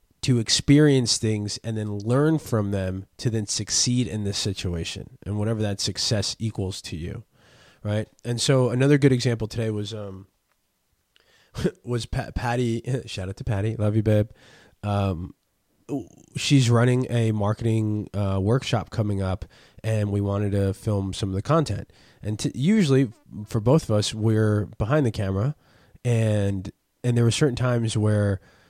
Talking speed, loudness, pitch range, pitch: 160 wpm, -24 LUFS, 100-125 Hz, 110 Hz